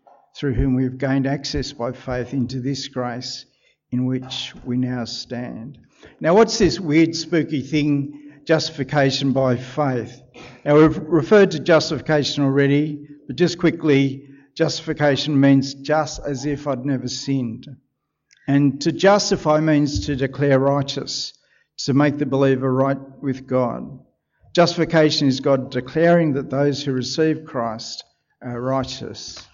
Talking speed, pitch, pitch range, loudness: 135 wpm, 140 Hz, 130-150 Hz, -20 LUFS